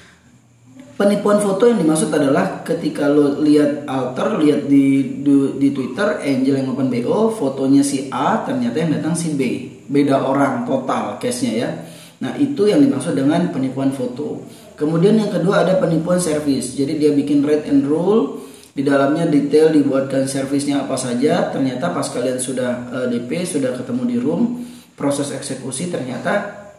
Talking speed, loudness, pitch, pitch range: 155 wpm, -18 LUFS, 145 Hz, 135-205 Hz